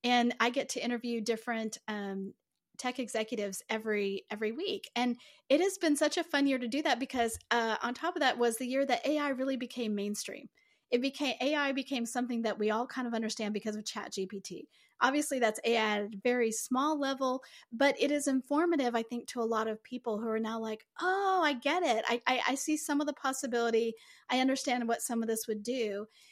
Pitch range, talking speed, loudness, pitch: 220-270 Hz, 215 wpm, -32 LUFS, 240 Hz